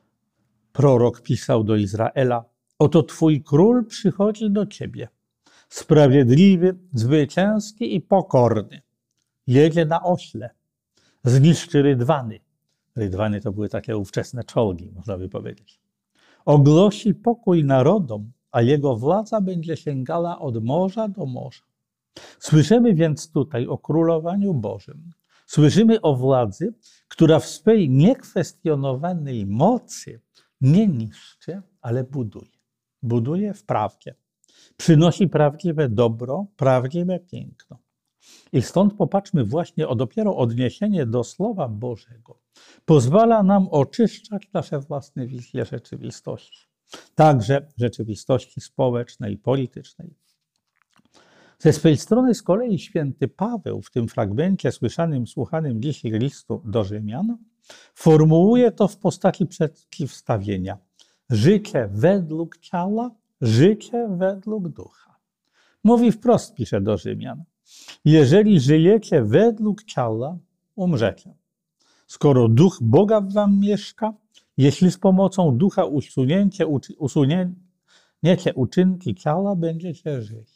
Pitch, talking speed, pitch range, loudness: 155 Hz, 105 wpm, 125-190 Hz, -20 LUFS